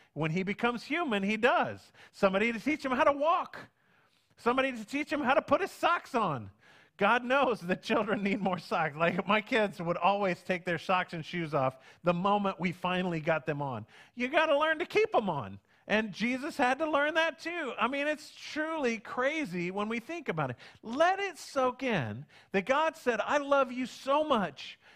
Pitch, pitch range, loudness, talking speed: 230 Hz, 180-285 Hz, -30 LUFS, 205 wpm